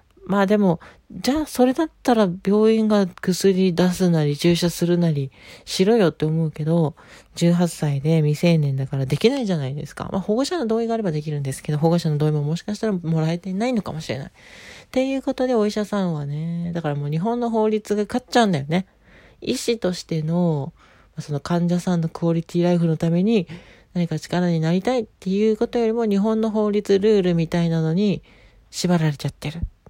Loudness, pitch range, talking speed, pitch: -21 LUFS, 160-210 Hz, 400 characters per minute, 175 Hz